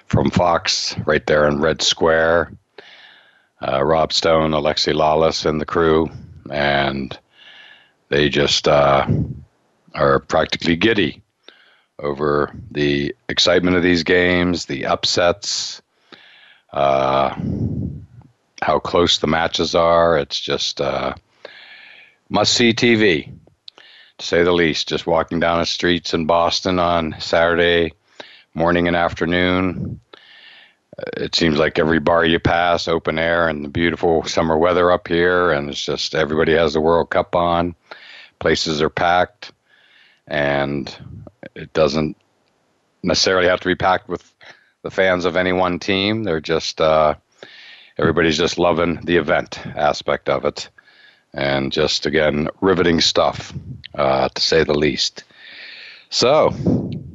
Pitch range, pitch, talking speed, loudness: 75-90 Hz, 85 Hz, 130 wpm, -17 LUFS